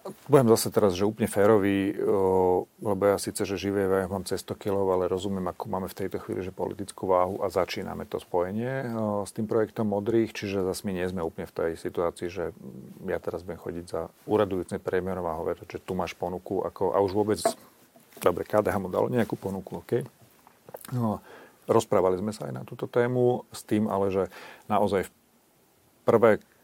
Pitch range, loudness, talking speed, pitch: 95-110 Hz, -27 LUFS, 190 wpm, 100 Hz